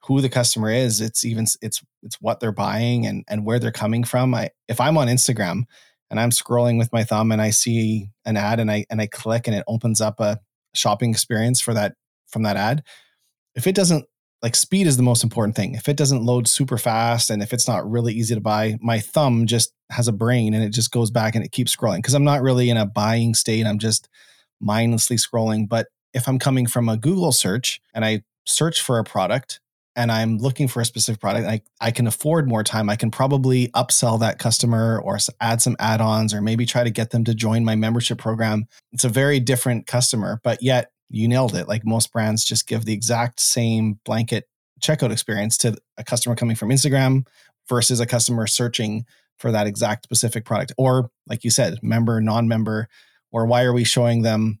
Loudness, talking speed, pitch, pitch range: -20 LUFS, 220 wpm, 115 Hz, 110-125 Hz